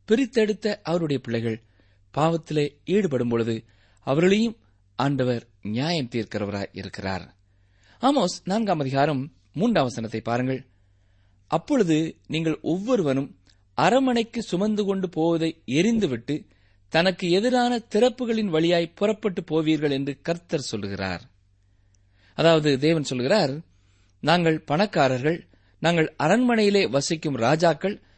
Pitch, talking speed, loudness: 150 Hz, 85 wpm, -24 LUFS